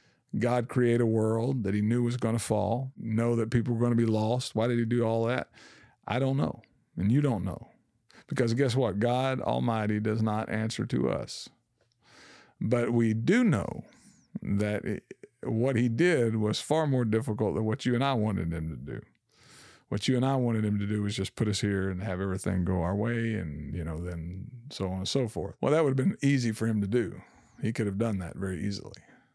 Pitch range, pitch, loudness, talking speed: 100-120 Hz, 110 Hz, -29 LUFS, 220 wpm